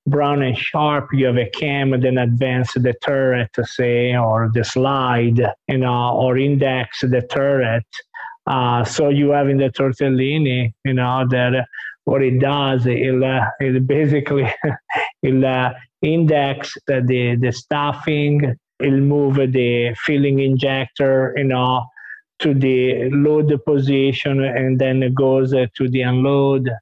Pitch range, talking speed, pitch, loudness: 125-140 Hz, 140 wpm, 130 Hz, -17 LUFS